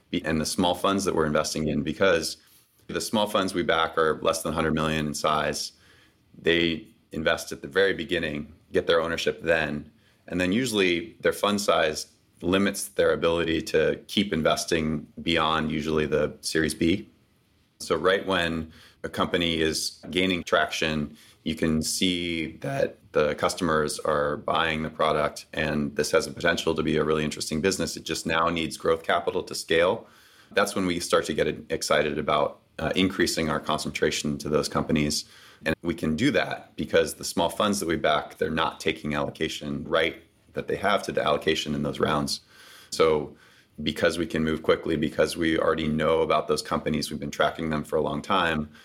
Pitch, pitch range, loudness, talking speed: 80 Hz, 75-85 Hz, -26 LUFS, 180 wpm